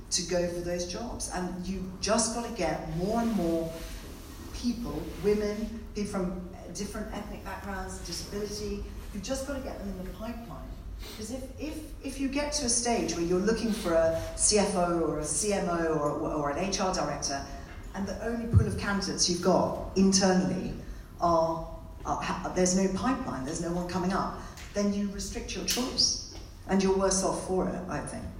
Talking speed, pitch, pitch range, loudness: 185 wpm, 185 Hz, 165-205 Hz, -30 LUFS